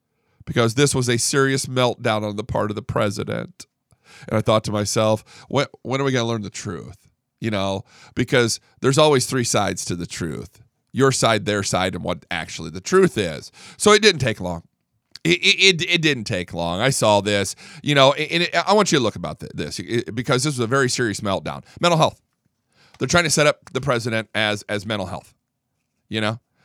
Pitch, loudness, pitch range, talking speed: 120 Hz, -20 LUFS, 105-140 Hz, 210 wpm